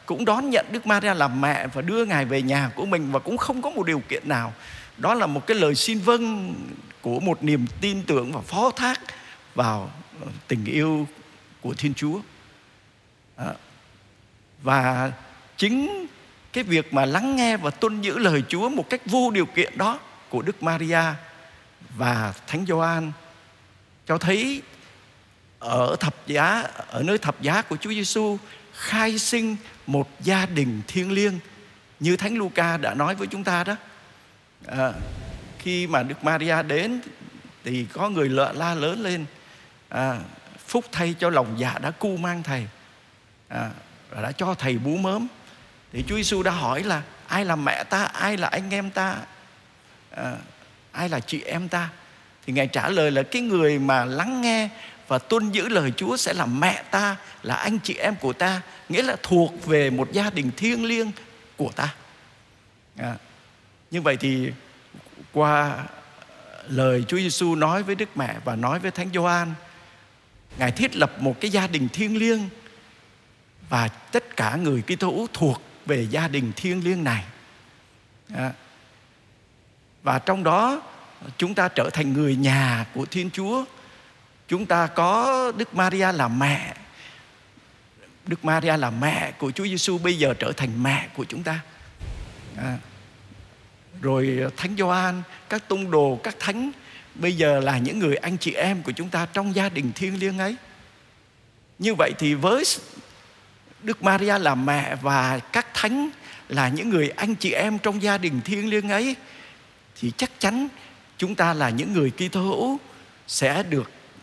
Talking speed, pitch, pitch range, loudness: 165 wpm, 165 Hz, 130-200 Hz, -24 LUFS